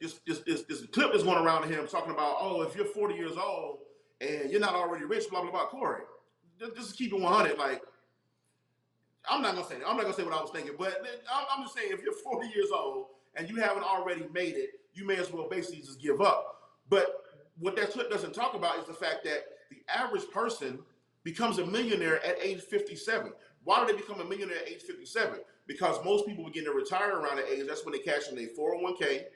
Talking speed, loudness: 225 wpm, -32 LUFS